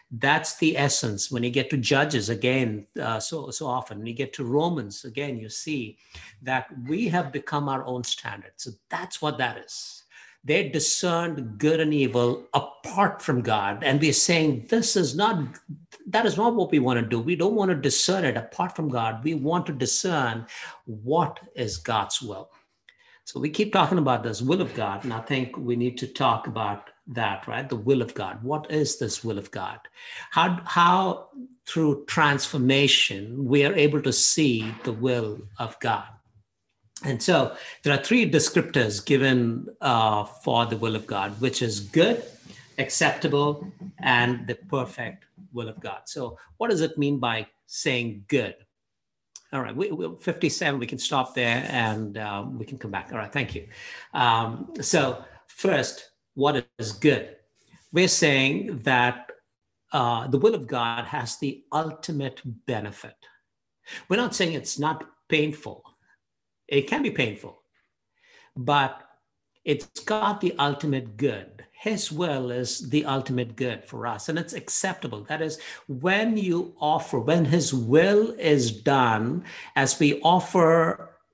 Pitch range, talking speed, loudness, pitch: 120-160 Hz, 165 wpm, -25 LUFS, 135 Hz